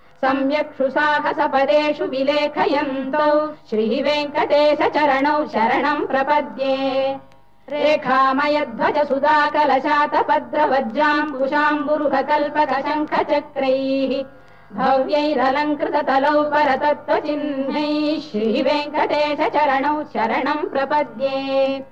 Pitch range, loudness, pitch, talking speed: 270-300 Hz, -19 LUFS, 295 Hz, 50 wpm